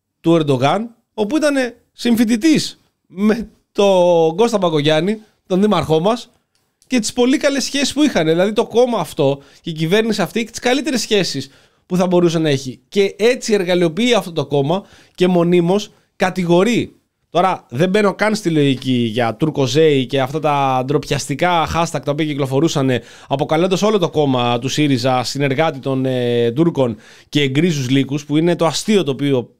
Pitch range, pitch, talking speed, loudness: 140-210 Hz, 170 Hz, 165 wpm, -16 LUFS